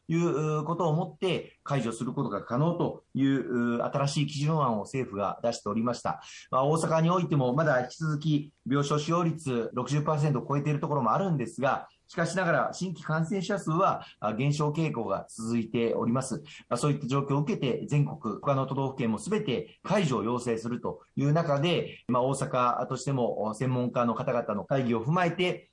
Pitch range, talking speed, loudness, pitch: 125-160 Hz, 365 characters per minute, -29 LUFS, 140 Hz